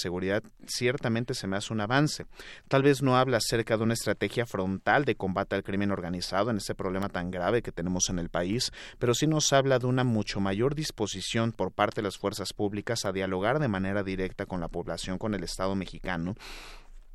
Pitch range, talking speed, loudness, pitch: 95-120 Hz, 205 wpm, -29 LUFS, 100 Hz